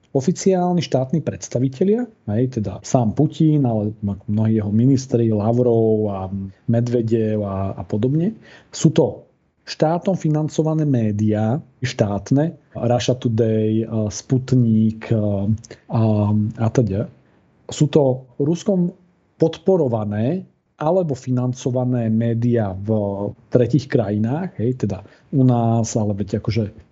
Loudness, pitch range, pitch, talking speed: -20 LUFS, 110-140 Hz, 120 Hz, 100 wpm